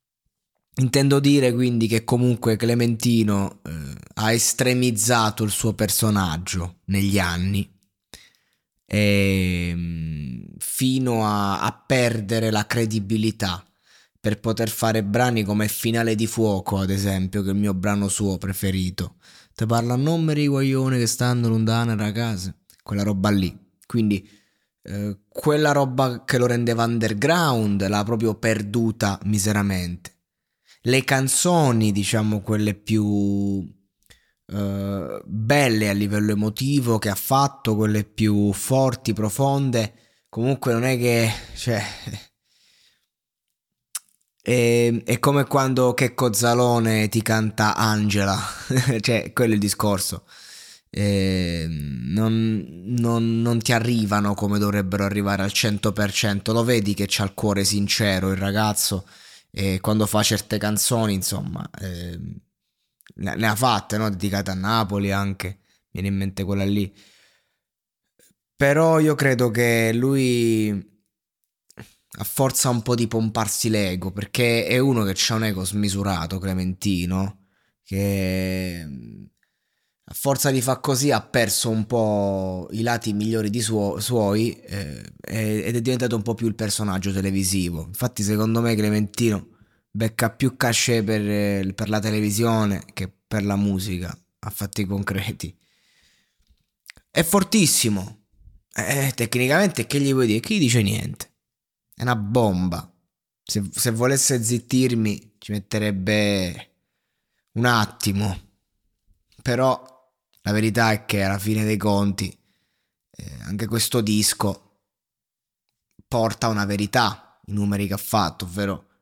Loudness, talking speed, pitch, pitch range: -22 LUFS, 125 wpm, 105 Hz, 100-115 Hz